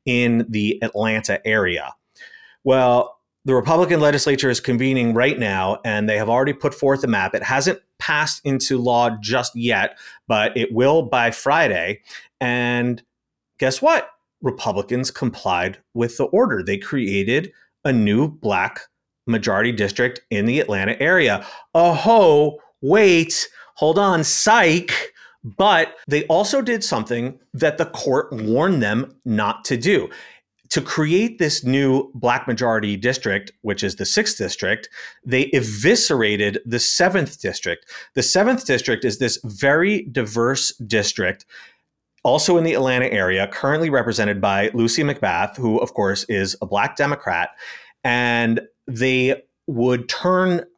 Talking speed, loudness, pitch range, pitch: 135 wpm, -19 LUFS, 115-150 Hz, 125 Hz